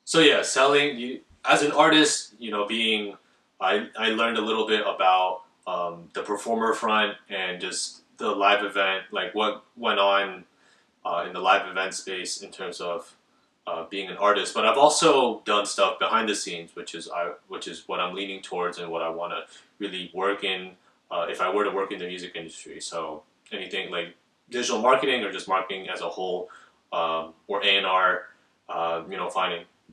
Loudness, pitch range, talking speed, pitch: -25 LUFS, 90-105 Hz, 190 wpm, 100 Hz